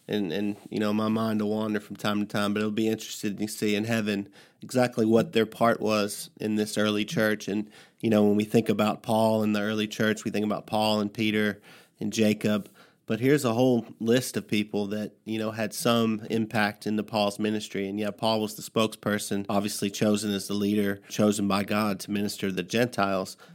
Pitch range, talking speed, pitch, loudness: 105-110 Hz, 210 wpm, 105 Hz, -27 LUFS